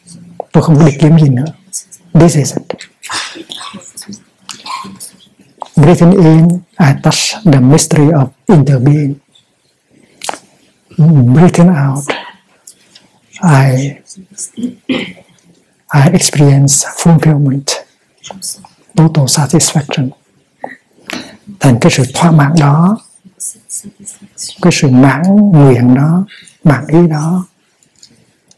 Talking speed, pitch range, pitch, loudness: 80 wpm, 145-180 Hz, 160 Hz, -9 LUFS